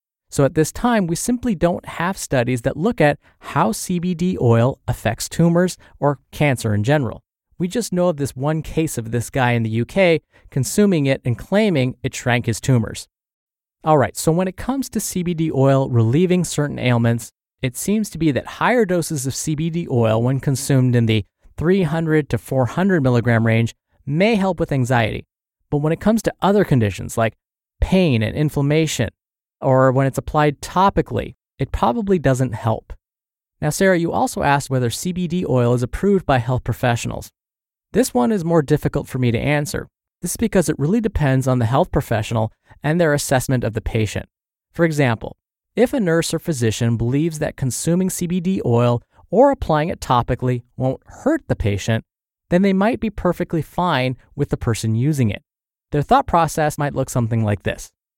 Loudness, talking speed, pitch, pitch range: -19 LUFS, 180 wpm, 140 Hz, 120-175 Hz